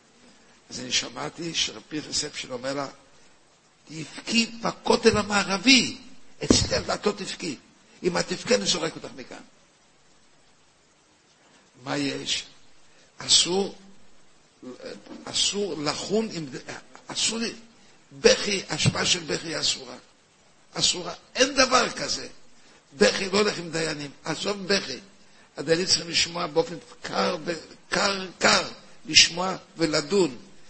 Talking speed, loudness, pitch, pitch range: 105 wpm, -24 LUFS, 185 Hz, 160-225 Hz